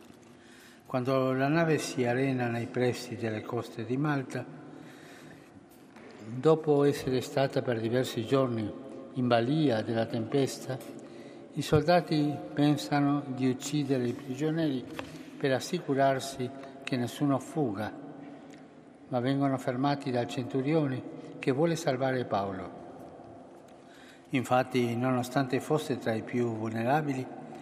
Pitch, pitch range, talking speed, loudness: 130 Hz, 120-145 Hz, 105 wpm, -30 LUFS